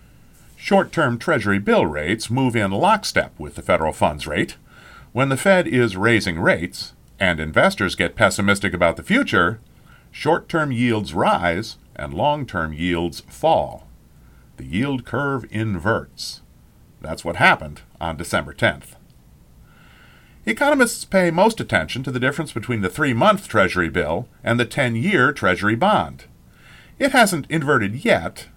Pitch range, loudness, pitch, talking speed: 100-150 Hz, -20 LUFS, 120 Hz, 145 wpm